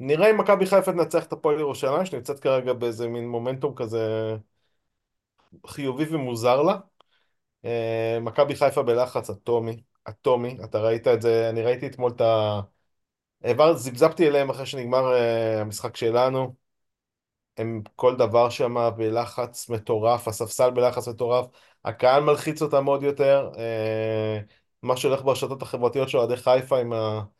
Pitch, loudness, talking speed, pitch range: 120 Hz, -24 LUFS, 130 wpm, 115-135 Hz